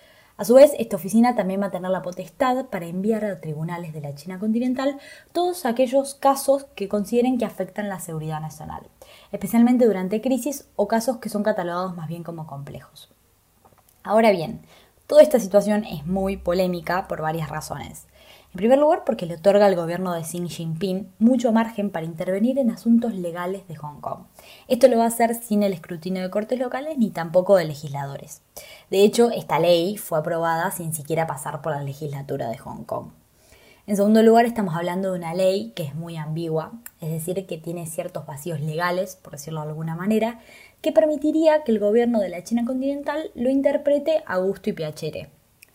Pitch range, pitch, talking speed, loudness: 170-235 Hz, 195 Hz, 185 wpm, -22 LUFS